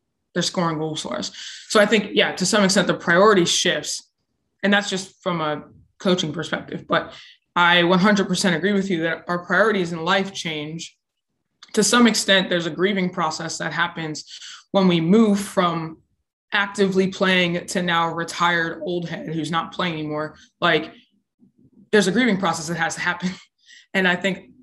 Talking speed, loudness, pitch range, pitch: 170 wpm, -20 LUFS, 165-200 Hz, 180 Hz